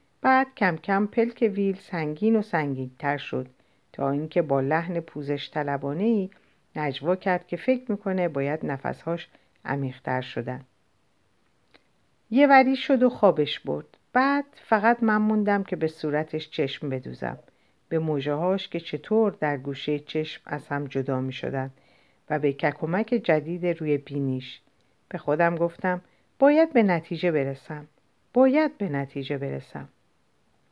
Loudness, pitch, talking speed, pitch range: -25 LUFS, 155 Hz, 135 wpm, 140-200 Hz